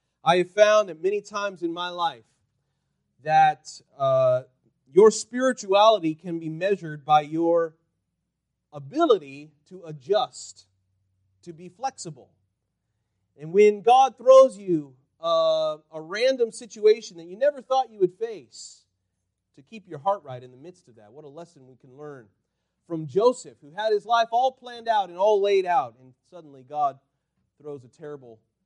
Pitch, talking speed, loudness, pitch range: 165 Hz, 155 wpm, -23 LUFS, 135-205 Hz